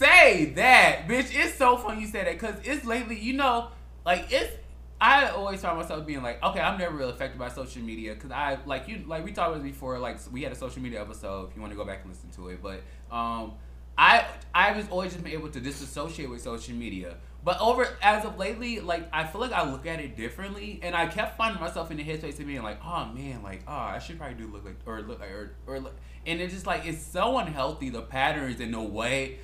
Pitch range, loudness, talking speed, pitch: 115-195 Hz, -26 LUFS, 255 wpm, 150 Hz